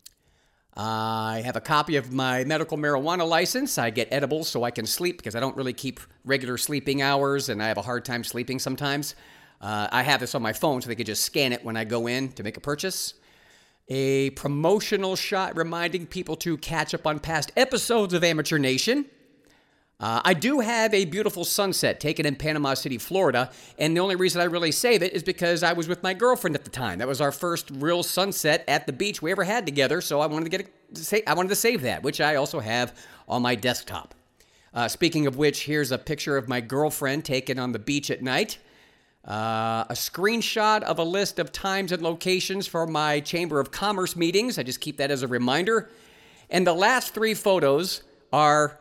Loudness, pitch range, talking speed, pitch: -25 LUFS, 130-180 Hz, 215 wpm, 150 Hz